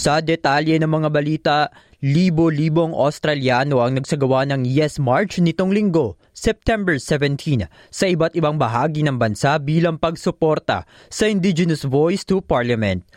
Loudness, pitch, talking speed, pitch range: -19 LUFS, 155 Hz, 130 wpm, 140-170 Hz